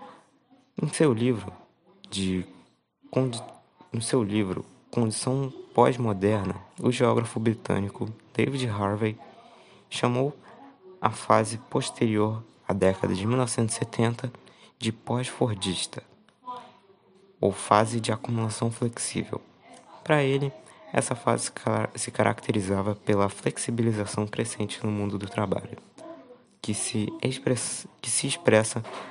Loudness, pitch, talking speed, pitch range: -27 LUFS, 115 Hz, 95 wpm, 105-130 Hz